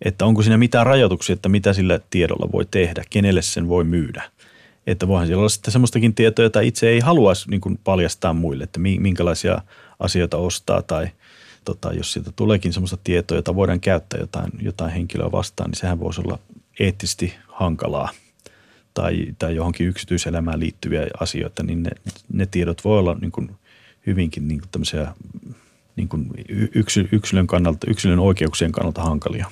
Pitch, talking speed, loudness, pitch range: 95 Hz, 160 wpm, -20 LUFS, 85-105 Hz